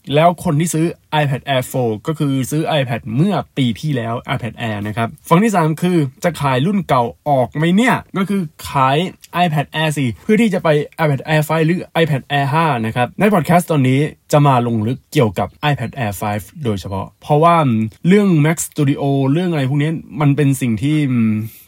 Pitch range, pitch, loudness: 125-165 Hz, 145 Hz, -16 LUFS